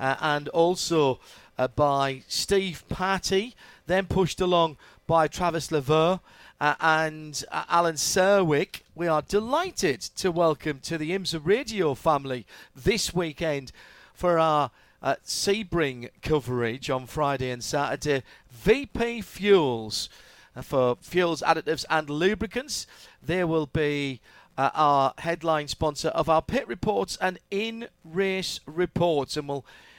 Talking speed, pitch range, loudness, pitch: 130 wpm, 145-185 Hz, -26 LUFS, 160 Hz